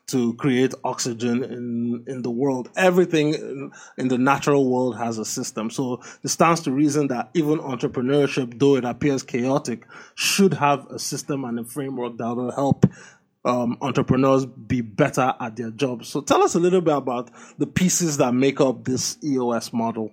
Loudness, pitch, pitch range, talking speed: -22 LUFS, 130 Hz, 120-145 Hz, 180 wpm